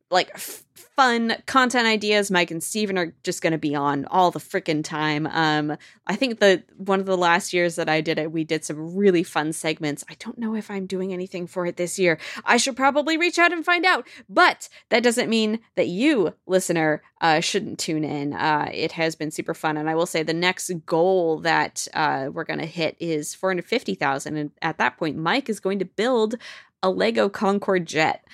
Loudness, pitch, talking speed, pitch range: -22 LUFS, 180 Hz, 215 wpm, 160-215 Hz